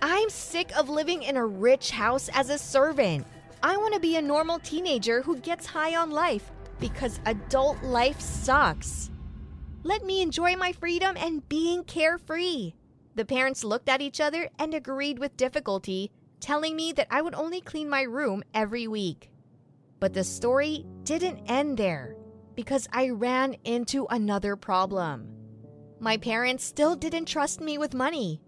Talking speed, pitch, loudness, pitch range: 160 wpm, 270 Hz, -27 LUFS, 210-315 Hz